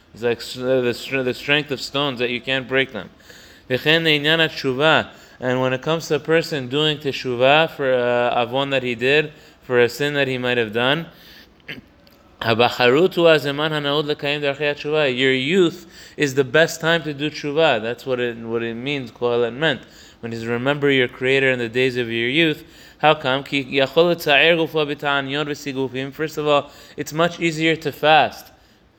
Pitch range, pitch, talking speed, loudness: 125-155 Hz, 140 Hz, 155 wpm, -19 LUFS